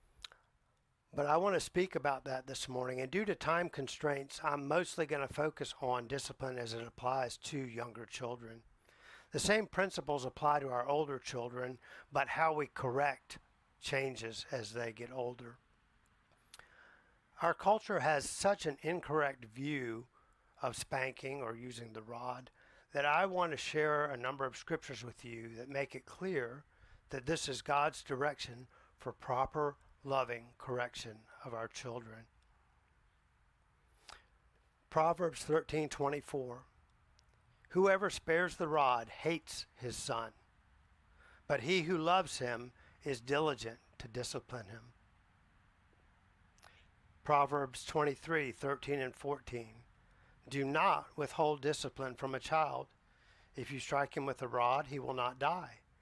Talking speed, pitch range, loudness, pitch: 135 wpm, 120-150 Hz, -37 LUFS, 135 Hz